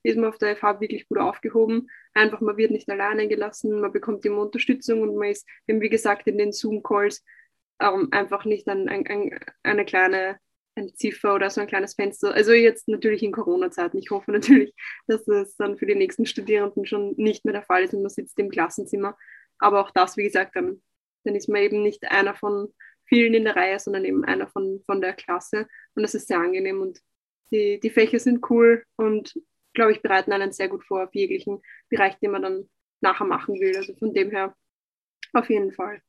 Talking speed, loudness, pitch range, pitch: 210 wpm, -23 LUFS, 200-230 Hz, 215 Hz